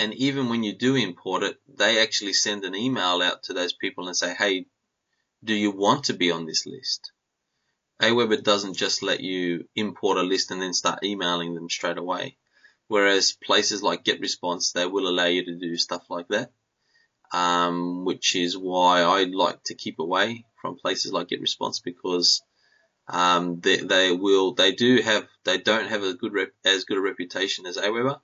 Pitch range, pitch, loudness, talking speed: 90-105 Hz, 95 Hz, -23 LUFS, 185 wpm